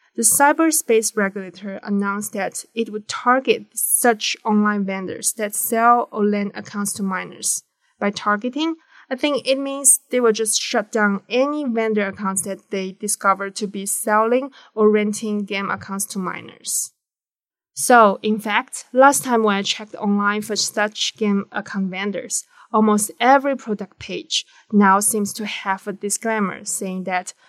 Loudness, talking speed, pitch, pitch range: -19 LUFS, 155 wpm, 210 Hz, 200-235 Hz